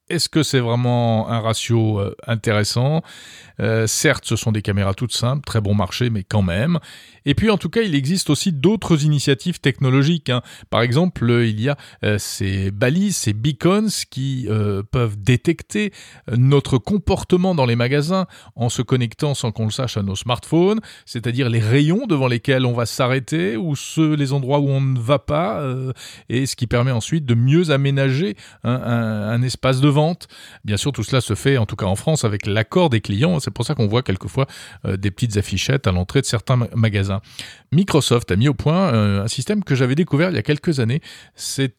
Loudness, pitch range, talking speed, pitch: -19 LUFS, 110-150 Hz, 200 wpm, 130 Hz